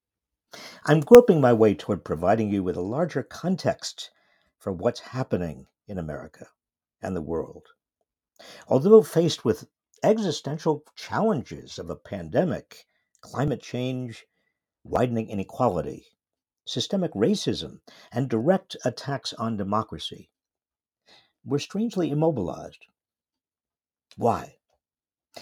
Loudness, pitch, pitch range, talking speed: -24 LUFS, 140 Hz, 110-165 Hz, 100 wpm